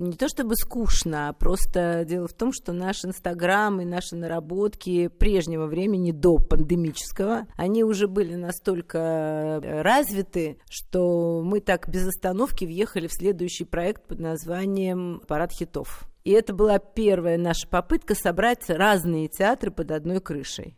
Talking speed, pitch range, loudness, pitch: 140 wpm, 170-205 Hz, -25 LUFS, 180 Hz